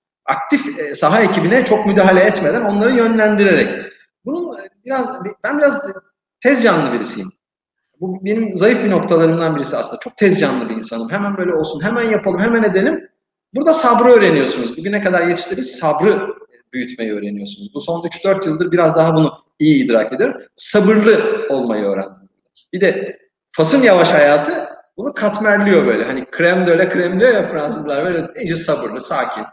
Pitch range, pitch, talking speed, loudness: 160-230 Hz, 195 Hz, 155 wpm, -15 LUFS